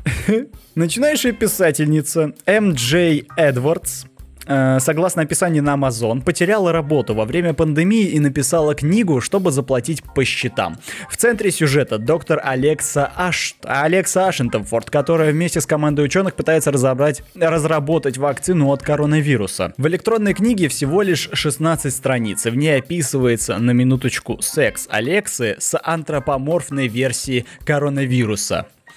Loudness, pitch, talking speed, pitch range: -18 LUFS, 150 Hz, 120 wpm, 135-170 Hz